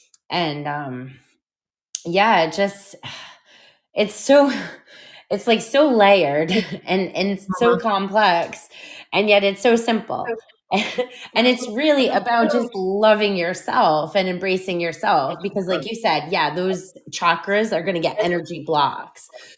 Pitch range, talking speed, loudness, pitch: 175-225 Hz, 130 wpm, -19 LUFS, 200 Hz